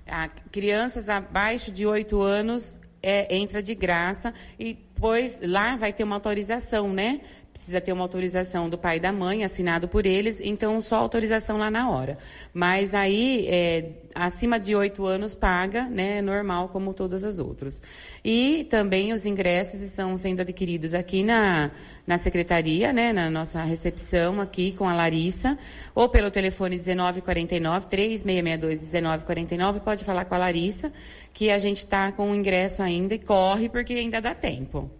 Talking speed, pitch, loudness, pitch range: 160 wpm, 195 Hz, -25 LUFS, 180-215 Hz